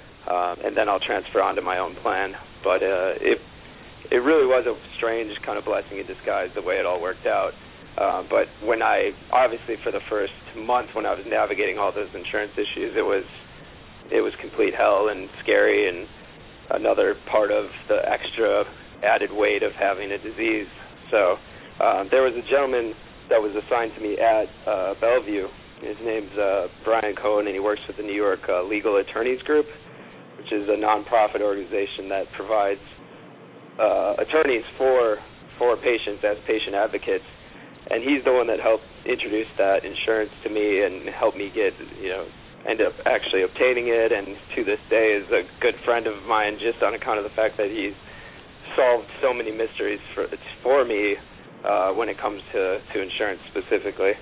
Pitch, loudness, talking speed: 320 Hz, -23 LUFS, 185 wpm